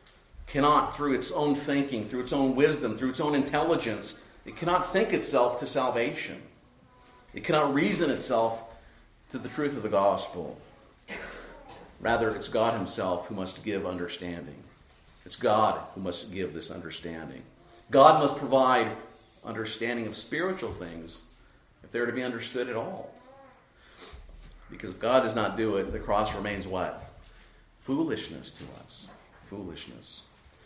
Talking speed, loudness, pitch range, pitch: 145 wpm, -28 LUFS, 95-130 Hz, 115 Hz